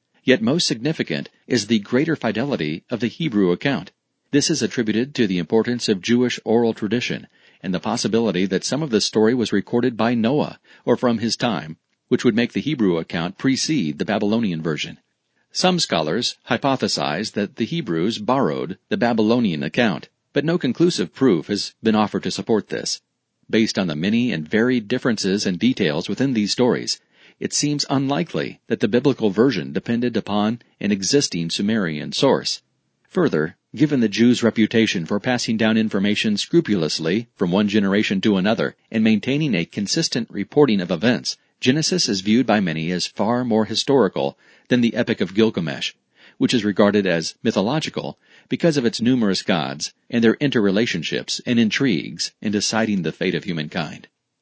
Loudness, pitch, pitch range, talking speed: -20 LUFS, 115 Hz, 105-125 Hz, 165 wpm